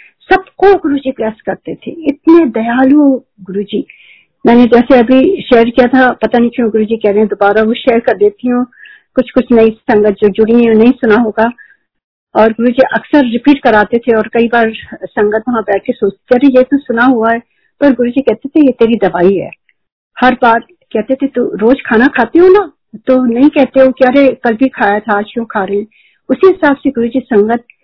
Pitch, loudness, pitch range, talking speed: 240 Hz, -10 LUFS, 220-265 Hz, 215 wpm